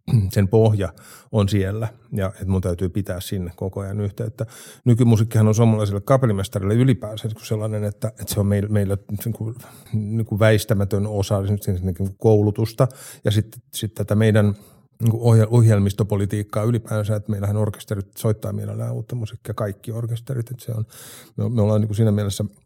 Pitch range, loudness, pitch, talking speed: 105-115 Hz, -21 LUFS, 110 Hz, 130 wpm